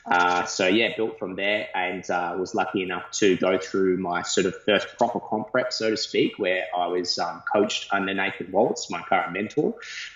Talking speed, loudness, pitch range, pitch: 205 wpm, -24 LUFS, 90-110 Hz, 95 Hz